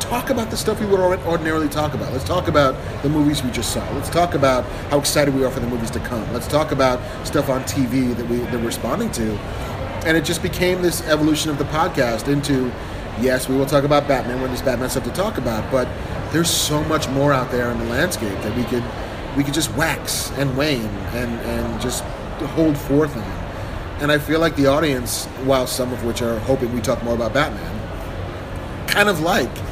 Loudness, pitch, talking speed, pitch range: -20 LUFS, 130 Hz, 220 wpm, 115-145 Hz